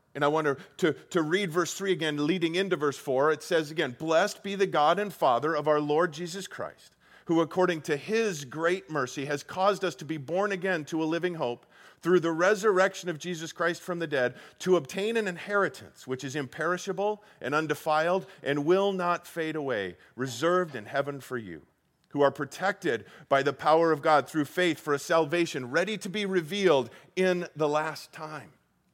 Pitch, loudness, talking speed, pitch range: 165 Hz, -28 LUFS, 195 wpm, 150-185 Hz